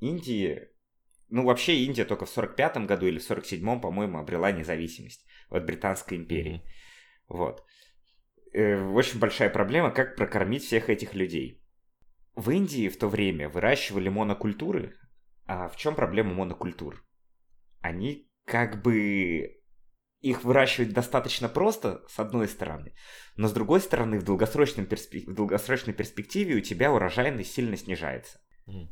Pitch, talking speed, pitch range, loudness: 105 Hz, 135 wpm, 95-125 Hz, -28 LUFS